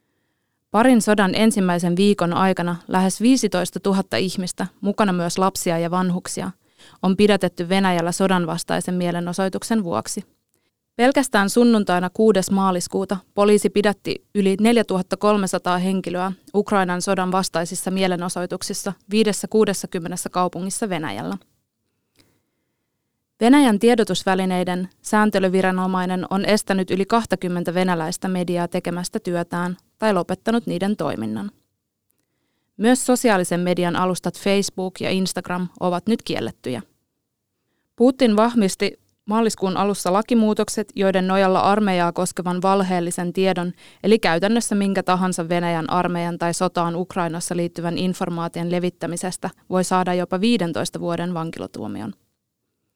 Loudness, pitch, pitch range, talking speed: -20 LUFS, 185 Hz, 180-205 Hz, 100 wpm